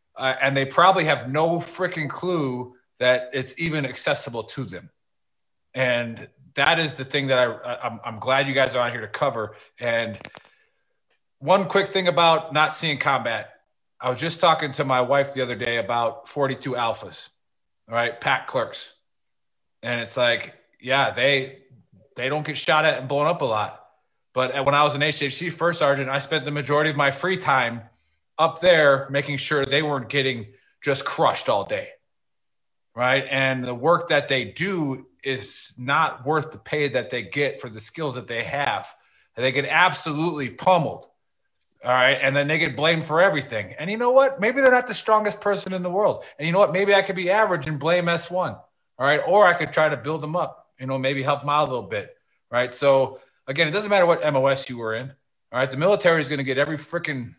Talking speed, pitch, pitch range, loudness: 205 wpm, 140 Hz, 130-165 Hz, -22 LUFS